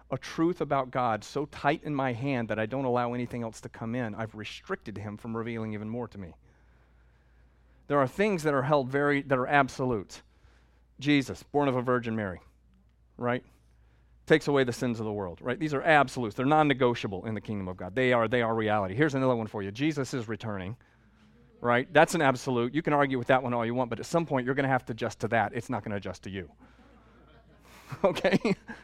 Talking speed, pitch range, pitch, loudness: 220 wpm, 105-140 Hz, 120 Hz, -29 LUFS